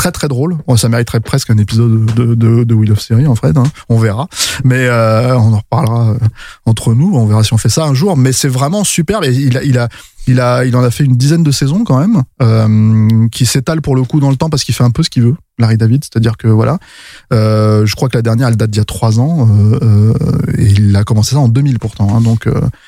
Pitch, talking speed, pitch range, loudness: 120 Hz, 270 wpm, 110-135 Hz, -11 LUFS